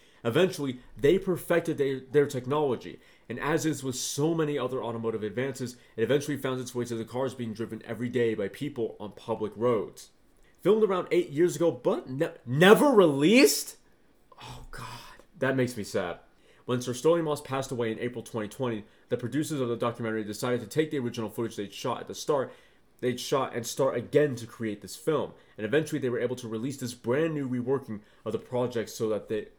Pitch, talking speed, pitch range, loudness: 125 Hz, 200 wpm, 115-145 Hz, -28 LUFS